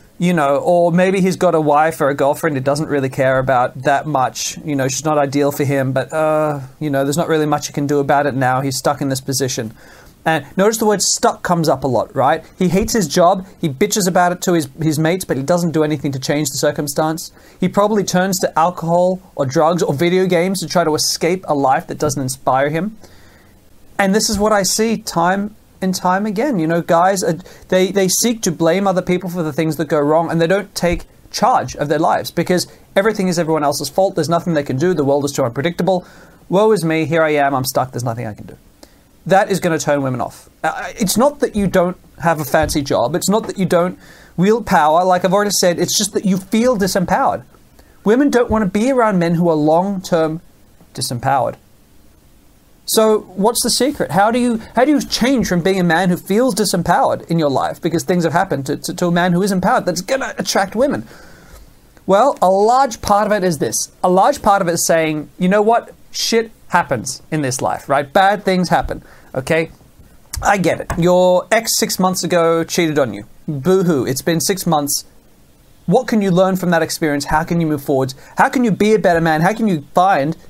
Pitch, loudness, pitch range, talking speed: 175 Hz, -16 LUFS, 150-195 Hz, 230 wpm